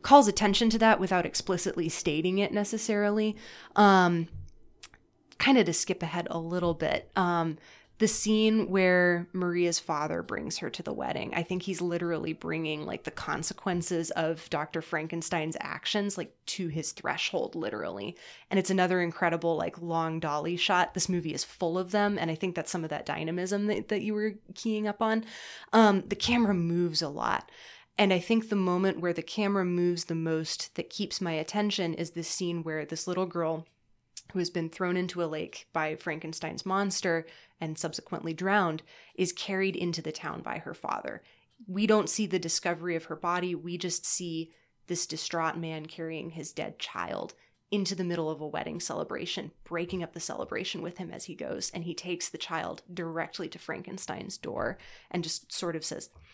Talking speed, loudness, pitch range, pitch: 185 wpm, -30 LUFS, 165-195 Hz, 175 Hz